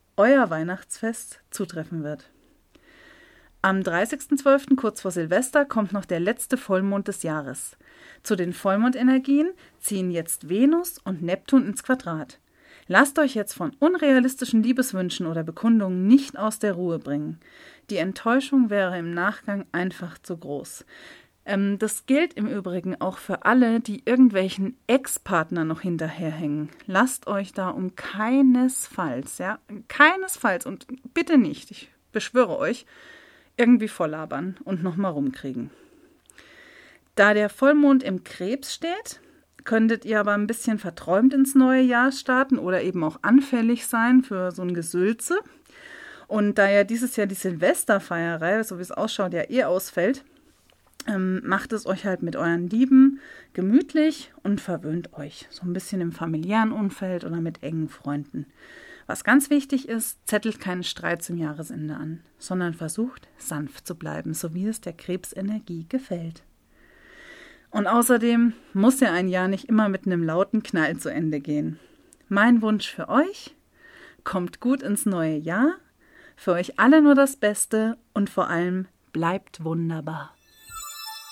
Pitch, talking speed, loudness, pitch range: 210 Hz, 140 wpm, -23 LUFS, 180-260 Hz